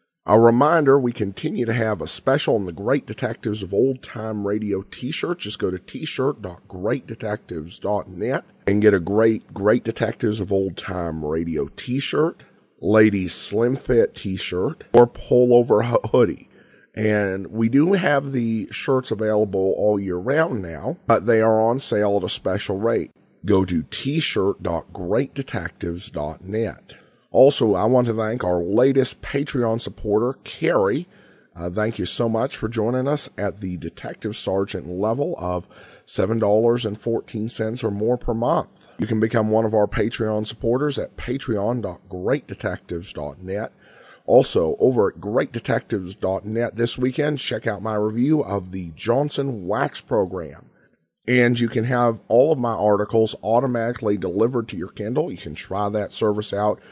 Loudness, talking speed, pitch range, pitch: -22 LUFS, 150 wpm, 100-120 Hz, 110 Hz